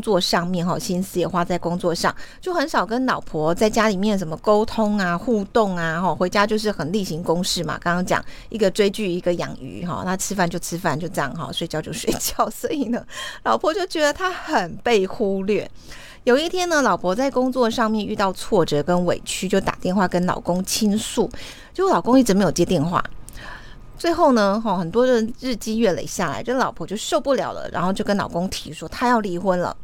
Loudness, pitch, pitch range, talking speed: -21 LUFS, 200 Hz, 175-230 Hz, 310 characters per minute